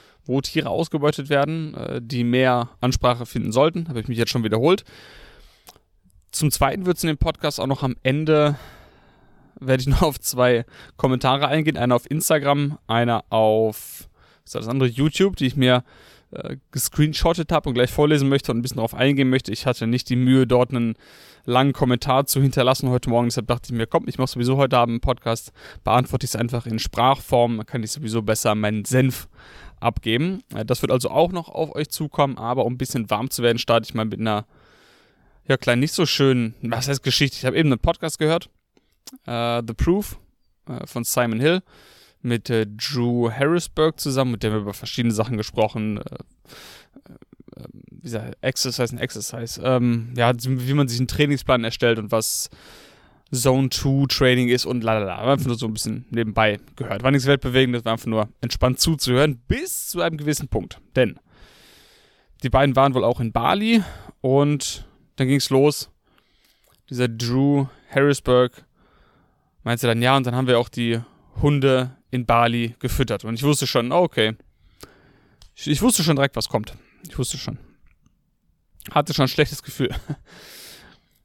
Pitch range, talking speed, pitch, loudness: 115-140 Hz, 180 wpm, 125 Hz, -21 LUFS